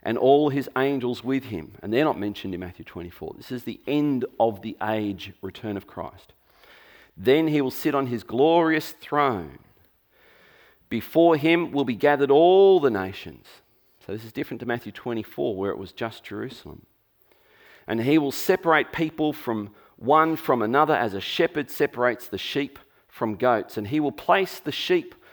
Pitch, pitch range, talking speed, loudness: 130 Hz, 110-150 Hz, 175 wpm, -23 LUFS